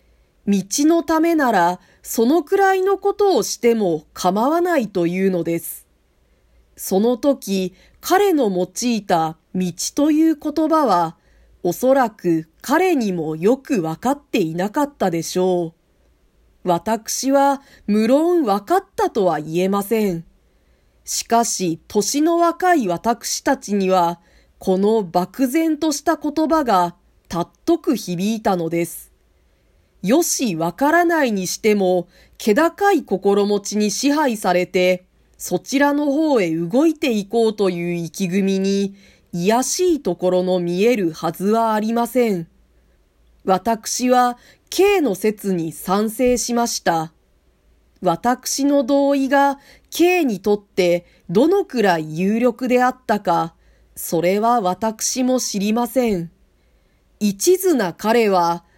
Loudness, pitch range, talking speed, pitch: -19 LUFS, 180-280 Hz, 230 characters per minute, 215 Hz